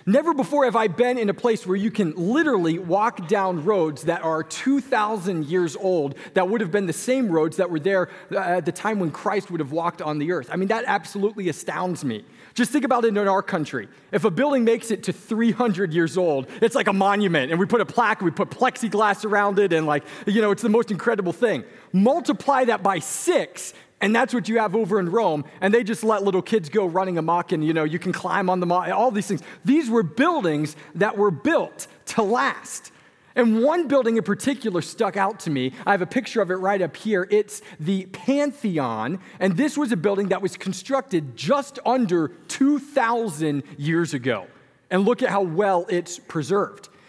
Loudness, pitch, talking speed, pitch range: -22 LUFS, 200 Hz, 215 wpm, 175-230 Hz